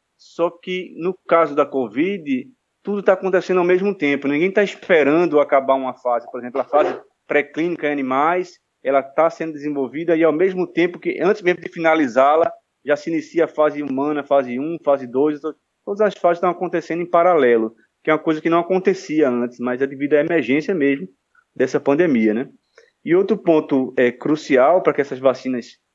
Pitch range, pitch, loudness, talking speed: 135-180 Hz, 155 Hz, -19 LUFS, 185 wpm